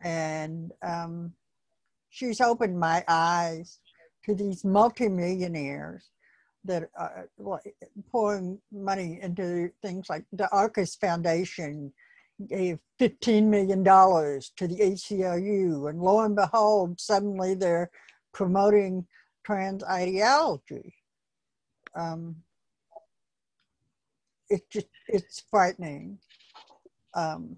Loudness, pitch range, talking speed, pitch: -27 LUFS, 170-205 Hz, 85 wpm, 185 Hz